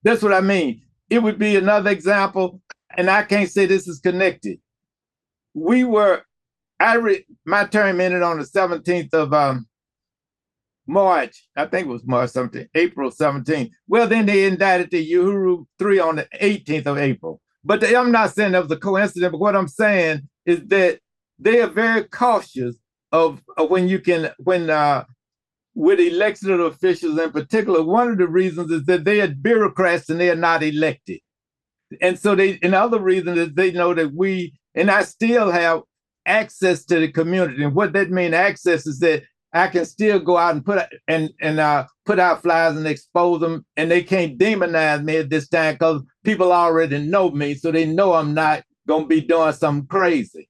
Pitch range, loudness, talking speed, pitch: 160-200 Hz, -18 LUFS, 190 wpm, 175 Hz